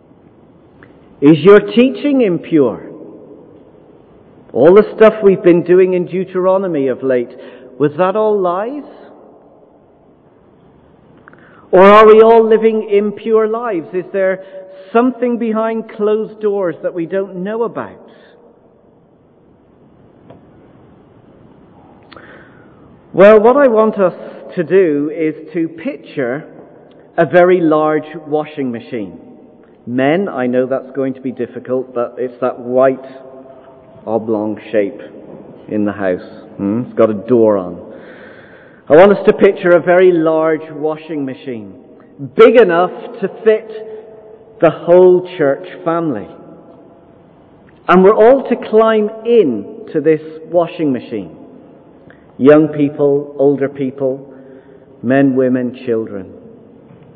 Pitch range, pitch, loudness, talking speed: 135-210 Hz, 170 Hz, -13 LUFS, 115 wpm